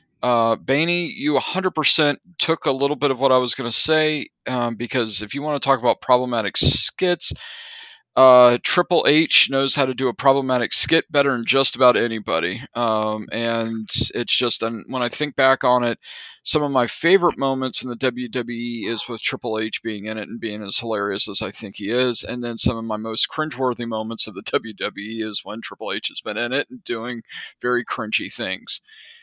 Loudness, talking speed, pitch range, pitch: -20 LUFS, 205 wpm, 115-145 Hz, 125 Hz